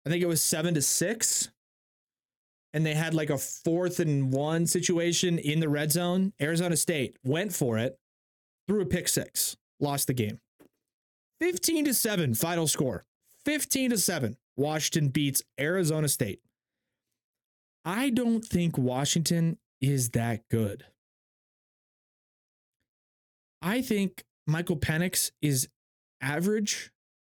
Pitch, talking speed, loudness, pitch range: 160 Hz, 125 wpm, -28 LUFS, 135-180 Hz